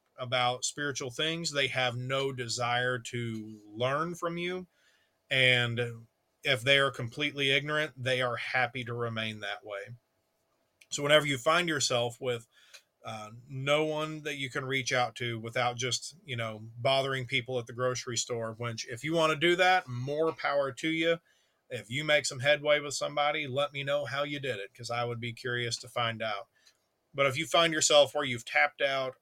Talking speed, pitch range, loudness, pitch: 185 wpm, 120-145 Hz, -30 LUFS, 135 Hz